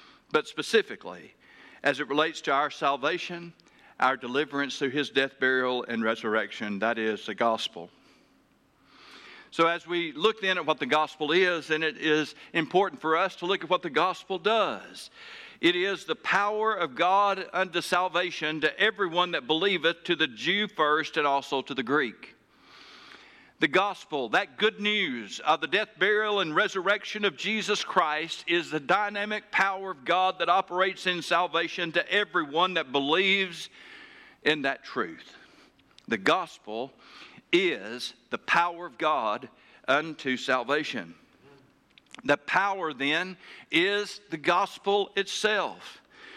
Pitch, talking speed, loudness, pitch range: 175 Hz, 145 wpm, -27 LUFS, 150-200 Hz